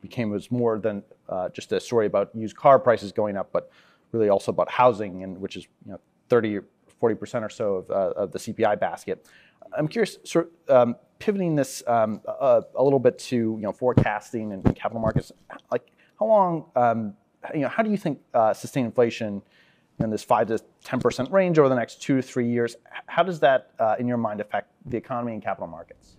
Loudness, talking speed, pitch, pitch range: -24 LUFS, 215 wpm, 120 Hz, 110-155 Hz